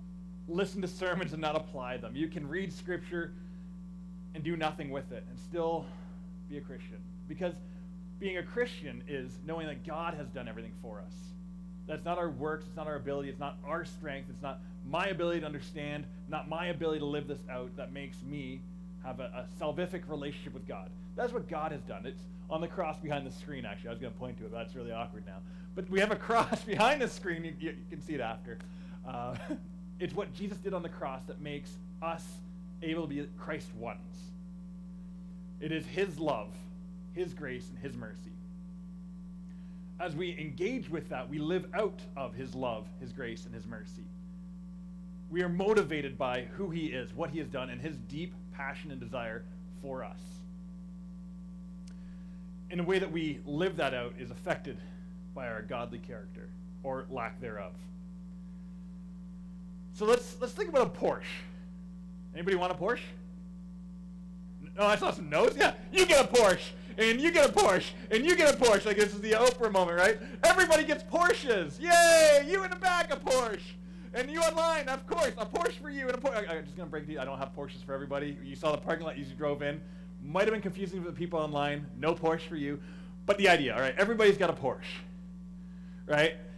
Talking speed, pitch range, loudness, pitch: 200 wpm, 165-180 Hz, -32 LUFS, 180 Hz